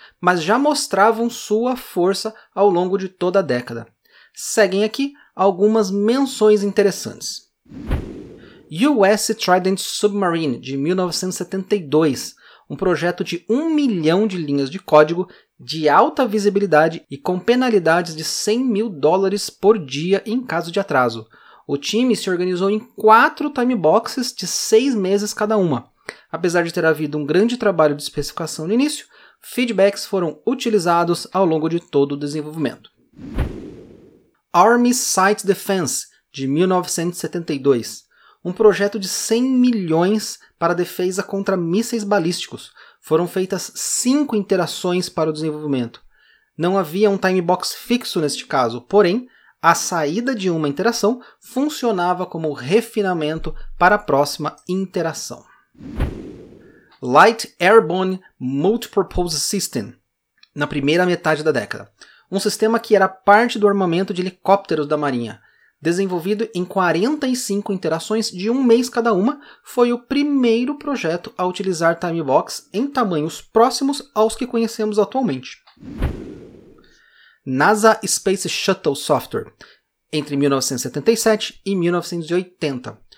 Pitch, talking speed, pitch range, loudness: 190 Hz, 125 wpm, 165-220 Hz, -19 LUFS